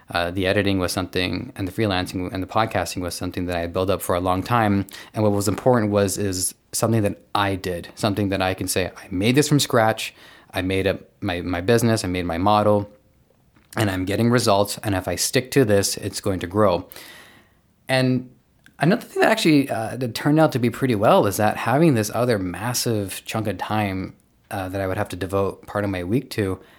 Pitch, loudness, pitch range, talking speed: 100 Hz, -22 LUFS, 95-115 Hz, 225 wpm